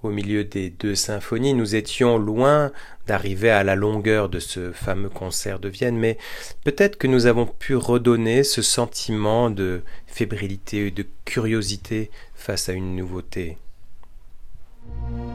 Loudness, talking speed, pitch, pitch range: -22 LUFS, 140 wpm, 105 Hz, 95-120 Hz